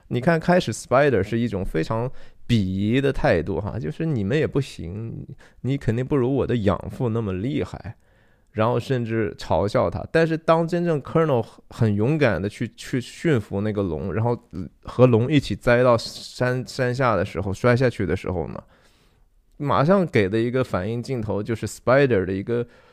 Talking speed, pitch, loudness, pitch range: 295 characters per minute, 115 Hz, -22 LUFS, 105-130 Hz